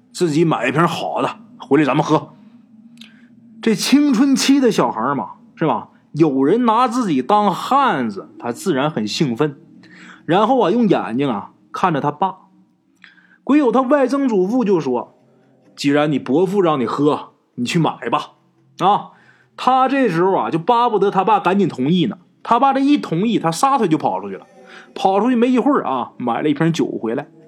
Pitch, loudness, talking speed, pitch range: 200 Hz, -17 LUFS, 250 characters per minute, 160-245 Hz